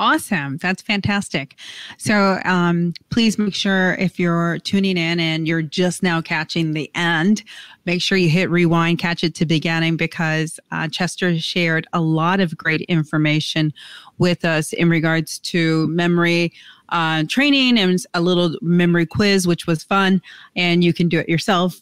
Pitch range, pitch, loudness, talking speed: 160-185 Hz, 170 Hz, -18 LUFS, 160 wpm